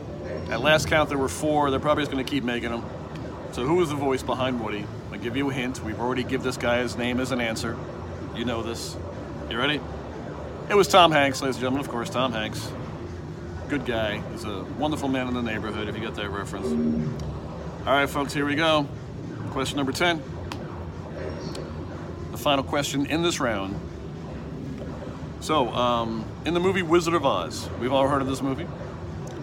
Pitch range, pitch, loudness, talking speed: 105-140 Hz, 125 Hz, -26 LUFS, 190 wpm